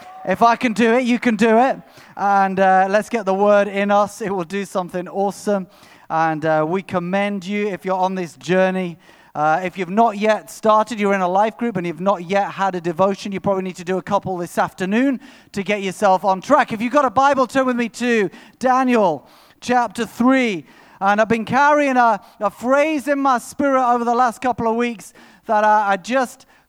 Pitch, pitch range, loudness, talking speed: 205 Hz, 190-240 Hz, -18 LUFS, 215 wpm